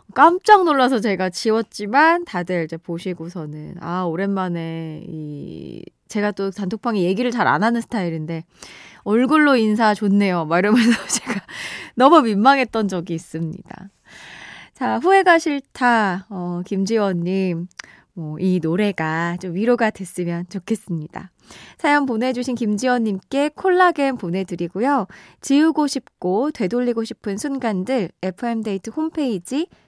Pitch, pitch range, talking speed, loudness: 210 Hz, 180-250 Hz, 290 characters per minute, -19 LUFS